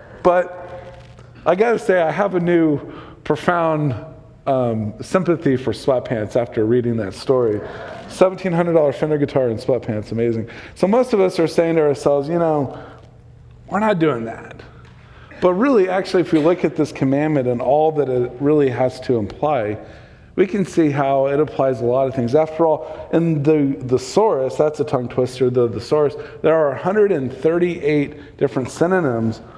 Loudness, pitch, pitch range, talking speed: -18 LUFS, 150 Hz, 125-165 Hz, 160 wpm